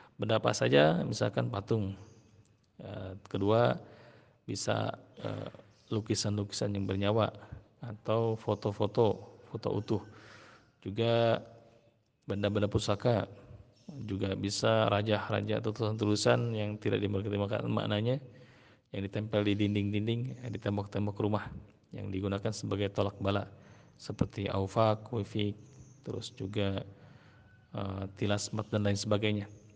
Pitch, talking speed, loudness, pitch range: 105 Hz, 95 wpm, -33 LUFS, 100-115 Hz